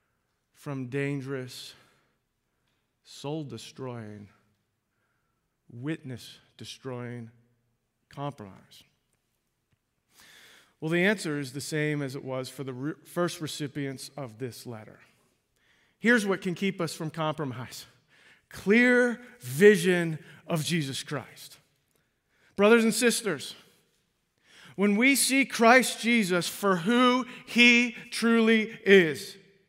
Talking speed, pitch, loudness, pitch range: 95 wpm, 155 Hz, -25 LUFS, 130-205 Hz